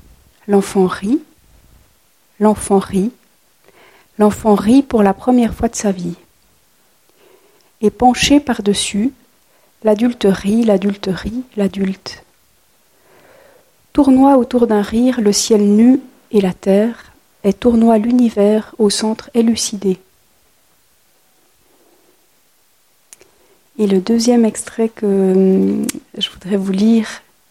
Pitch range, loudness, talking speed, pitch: 200-245 Hz, -14 LUFS, 100 wpm, 220 Hz